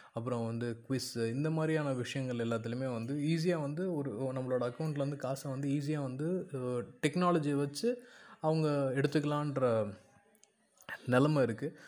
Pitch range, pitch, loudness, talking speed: 125-155 Hz, 140 Hz, -34 LUFS, 115 wpm